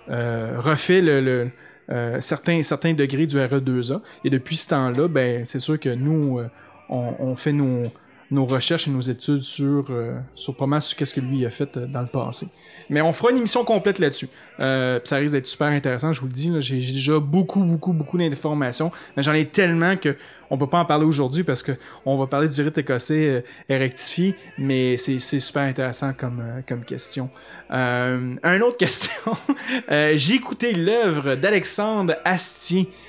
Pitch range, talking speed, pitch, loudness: 130-165 Hz, 195 wpm, 145 Hz, -21 LUFS